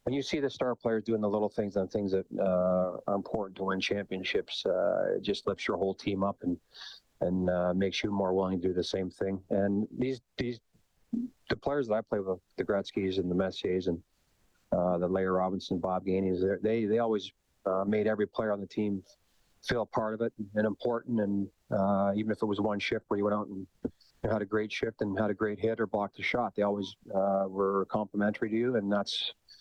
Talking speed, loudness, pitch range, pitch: 230 wpm, -32 LUFS, 95-110 Hz, 100 Hz